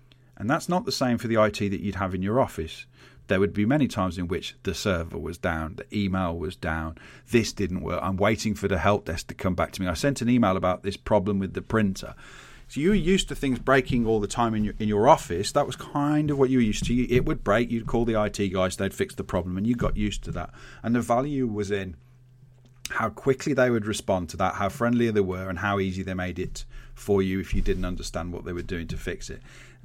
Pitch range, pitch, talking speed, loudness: 95-125 Hz, 105 Hz, 260 wpm, -26 LUFS